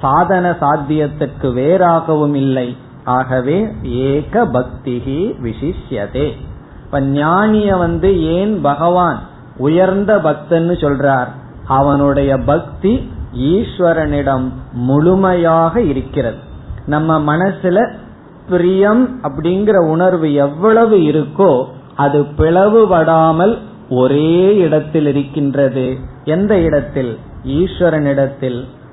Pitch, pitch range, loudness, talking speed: 150 Hz, 135-180 Hz, -14 LUFS, 60 wpm